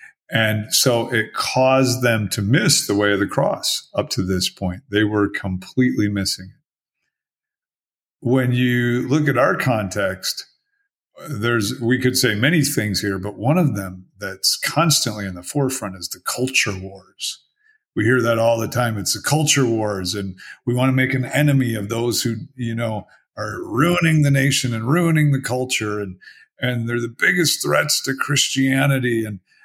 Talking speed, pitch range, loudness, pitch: 175 wpm, 105-135 Hz, -19 LUFS, 120 Hz